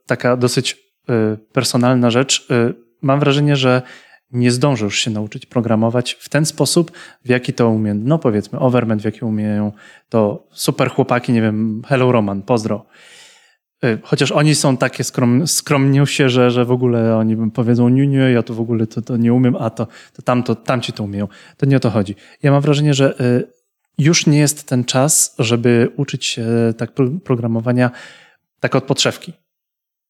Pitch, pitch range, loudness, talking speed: 125 Hz, 115-140 Hz, -16 LUFS, 170 wpm